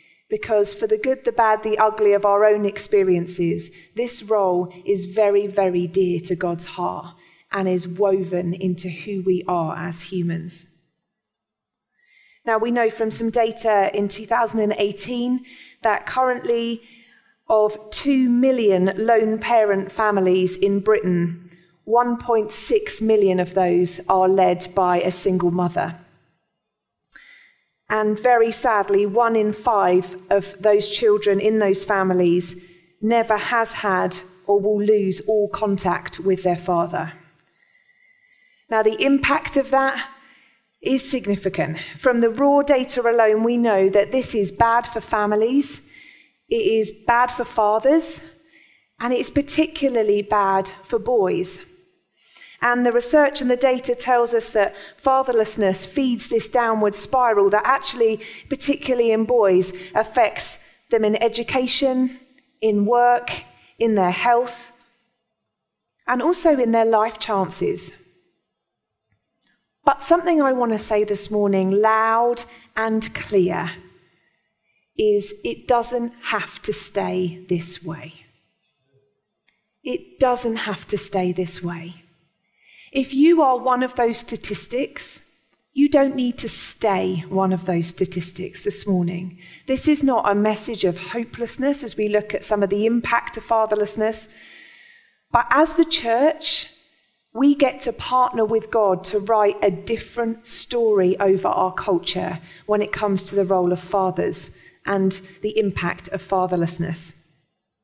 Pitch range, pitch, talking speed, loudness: 190-245 Hz, 215 Hz, 130 wpm, -20 LUFS